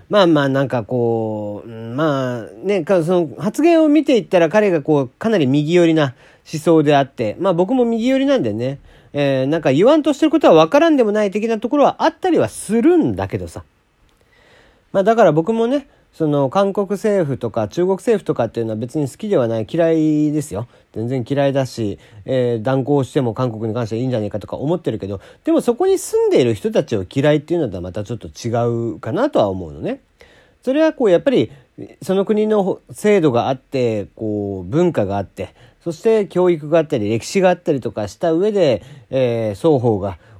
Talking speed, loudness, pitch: 385 characters per minute, -17 LUFS, 155 Hz